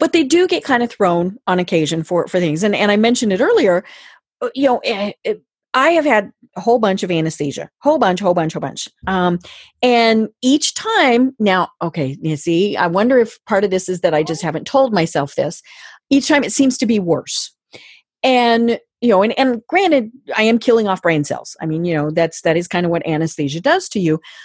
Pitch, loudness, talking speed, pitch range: 205 Hz, -16 LUFS, 220 wpm, 170-255 Hz